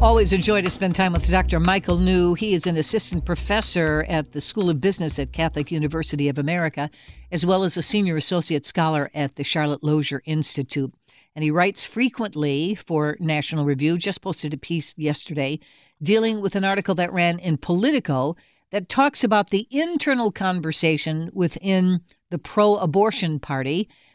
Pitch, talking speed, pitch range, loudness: 170 Hz, 170 wpm, 150-195 Hz, -22 LUFS